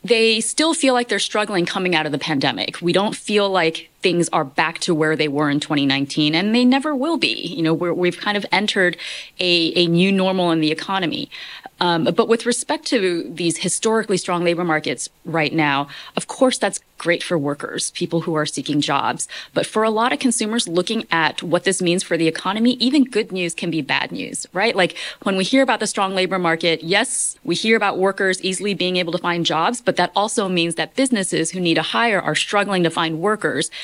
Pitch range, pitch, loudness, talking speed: 165-215 Hz, 180 Hz, -19 LUFS, 220 wpm